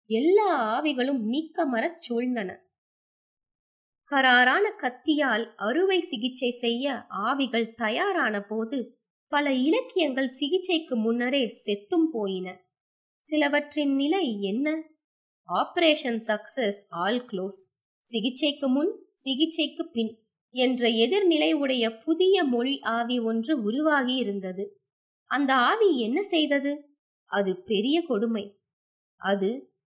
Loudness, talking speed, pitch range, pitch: -26 LUFS, 90 wpm, 225-310 Hz, 255 Hz